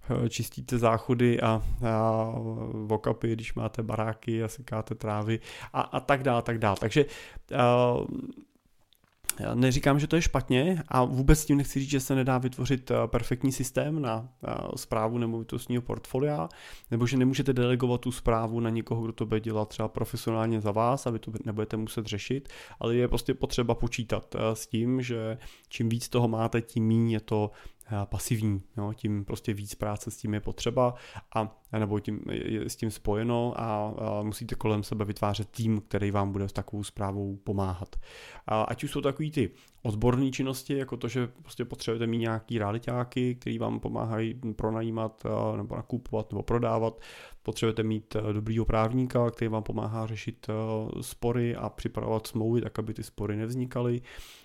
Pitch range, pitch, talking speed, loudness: 110-125 Hz, 115 Hz, 165 wpm, -30 LUFS